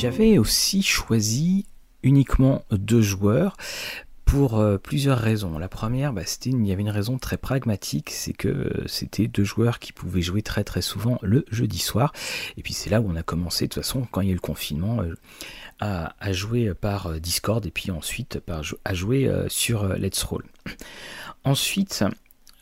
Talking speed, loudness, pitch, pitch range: 195 wpm, -24 LUFS, 105 Hz, 95-130 Hz